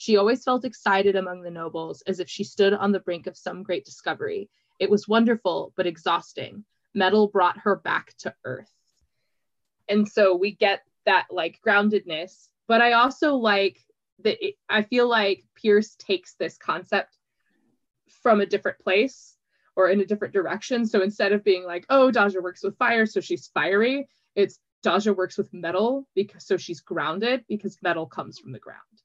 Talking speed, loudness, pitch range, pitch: 180 wpm, -24 LUFS, 185-230 Hz, 200 Hz